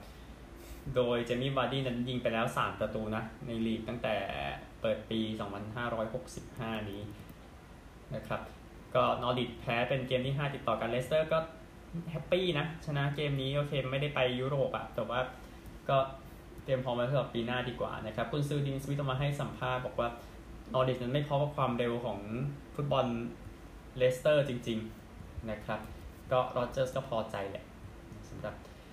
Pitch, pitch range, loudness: 125 Hz, 110-135 Hz, -34 LUFS